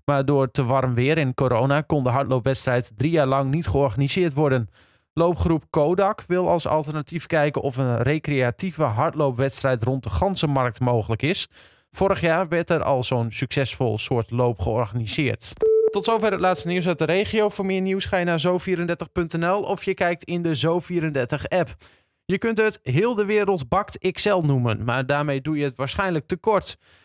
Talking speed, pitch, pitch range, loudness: 175 wpm, 150 Hz, 130-180 Hz, -22 LUFS